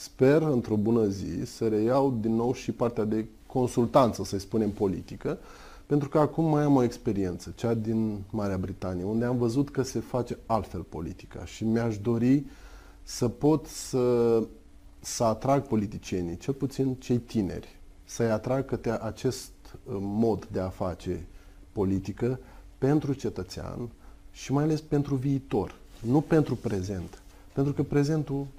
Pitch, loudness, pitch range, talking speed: 115 Hz, -28 LUFS, 95-130 Hz, 145 wpm